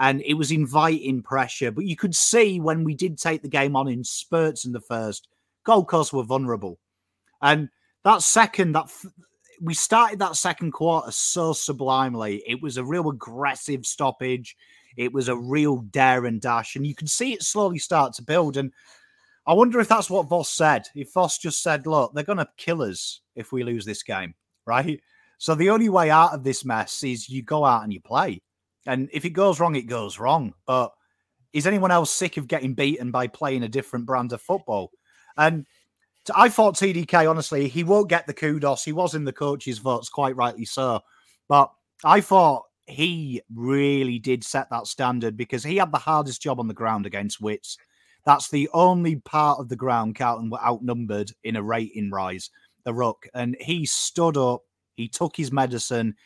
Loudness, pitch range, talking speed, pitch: -23 LUFS, 120-165 Hz, 195 wpm, 140 Hz